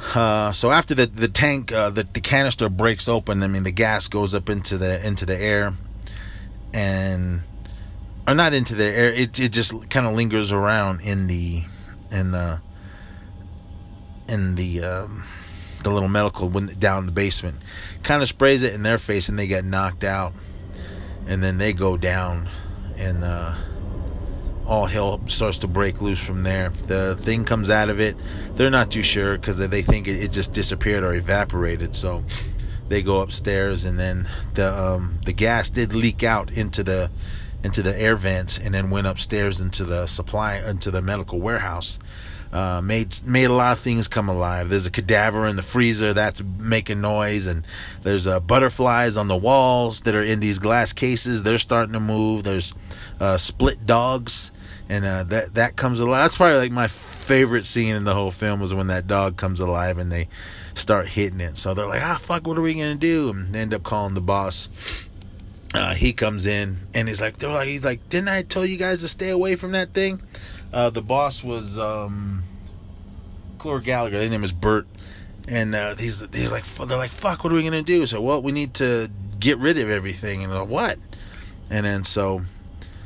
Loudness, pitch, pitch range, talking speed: -21 LUFS, 100 Hz, 95-115 Hz, 195 wpm